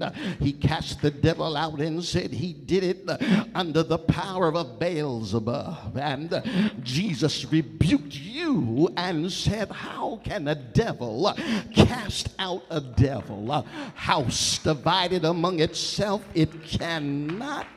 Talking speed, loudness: 125 wpm, -26 LUFS